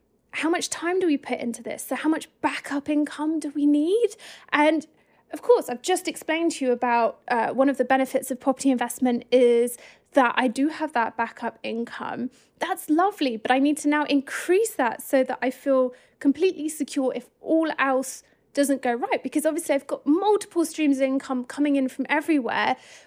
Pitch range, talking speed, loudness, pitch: 255-310 Hz, 195 wpm, -24 LUFS, 280 Hz